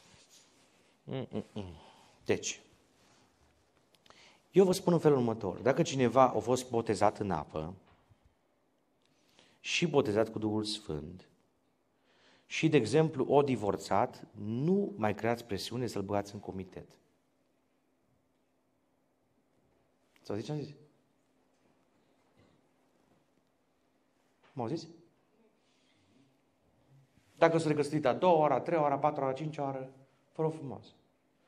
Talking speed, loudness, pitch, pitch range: 110 wpm, -31 LUFS, 130 Hz, 105-150 Hz